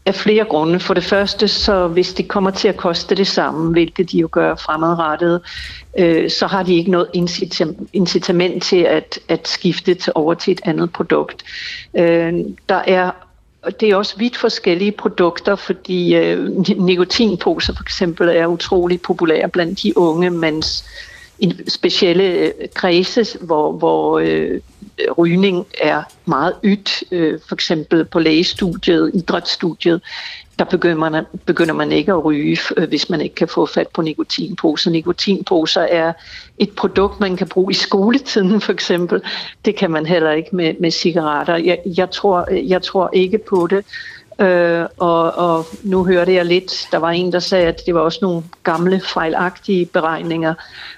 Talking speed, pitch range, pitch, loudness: 160 wpm, 170-195 Hz, 180 Hz, -16 LUFS